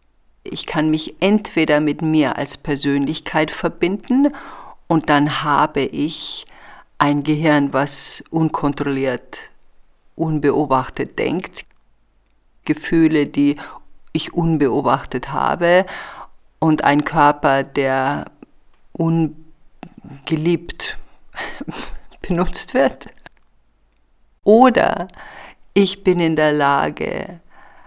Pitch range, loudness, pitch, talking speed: 145-165 Hz, -18 LUFS, 155 Hz, 80 wpm